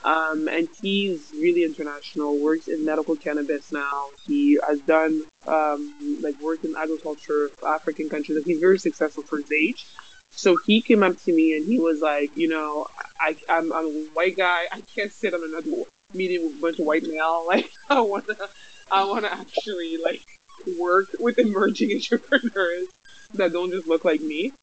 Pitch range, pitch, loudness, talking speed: 155-205 Hz, 165 Hz, -23 LUFS, 190 wpm